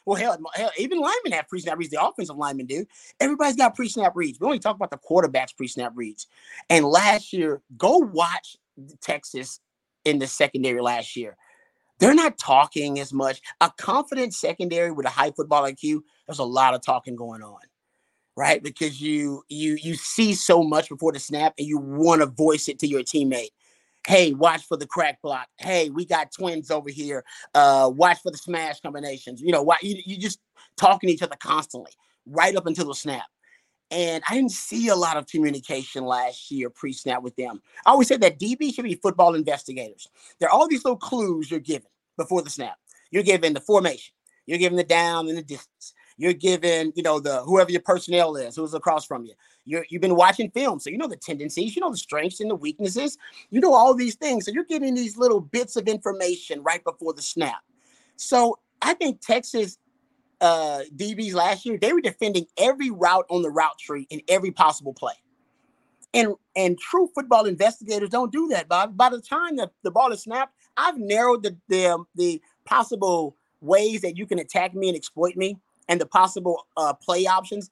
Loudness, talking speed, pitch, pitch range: -22 LUFS, 200 wpm, 175 Hz, 150-225 Hz